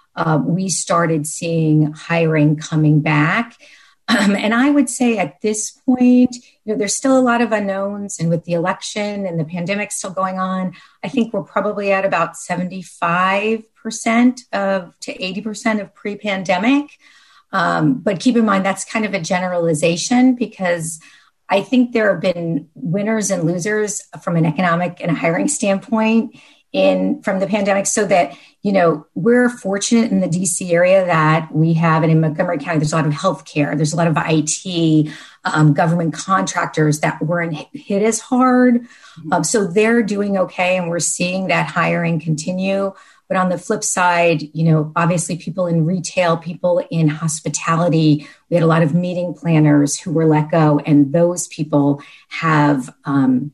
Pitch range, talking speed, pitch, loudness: 160-210 Hz, 175 wpm, 180 Hz, -17 LUFS